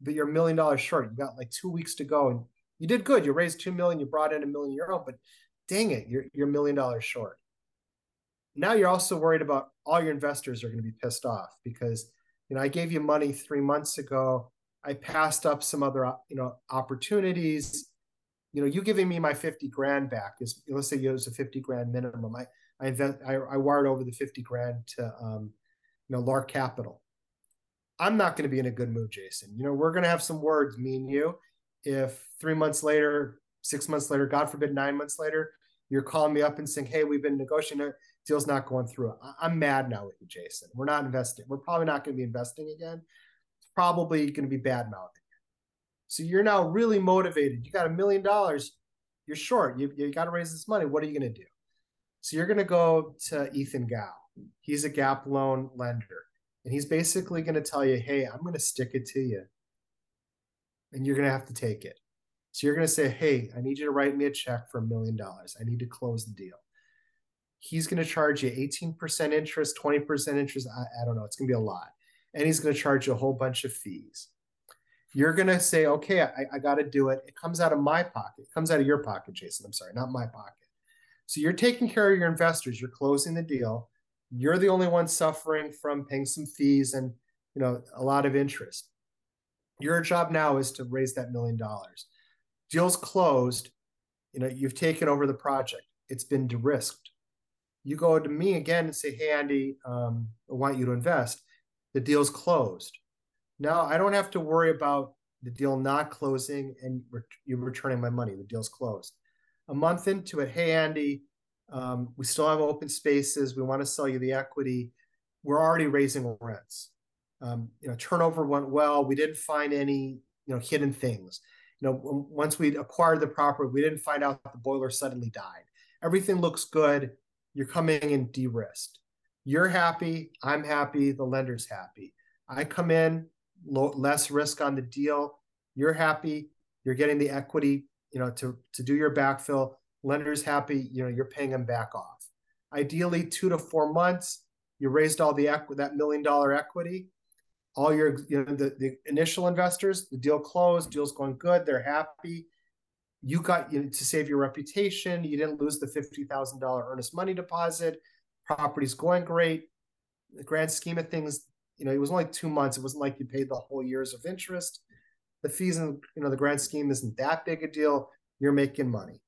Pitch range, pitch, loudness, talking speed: 130-160 Hz, 145 Hz, -29 LUFS, 210 wpm